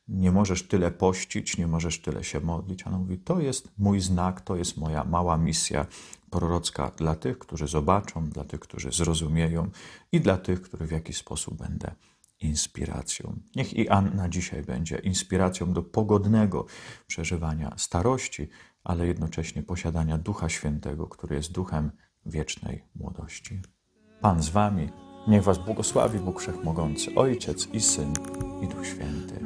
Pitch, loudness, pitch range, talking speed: 90 Hz, -28 LUFS, 80-95 Hz, 145 wpm